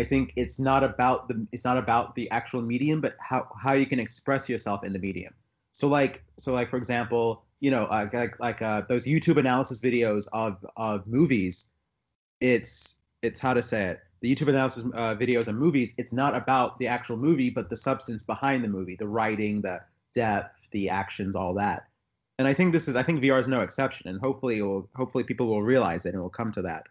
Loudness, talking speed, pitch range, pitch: -27 LUFS, 225 wpm, 105-130 Hz, 120 Hz